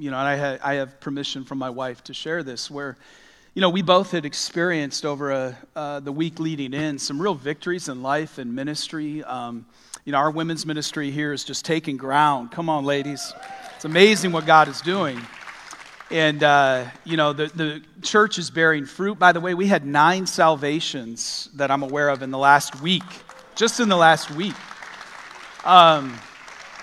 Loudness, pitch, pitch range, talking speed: -21 LUFS, 150 Hz, 140-165 Hz, 190 wpm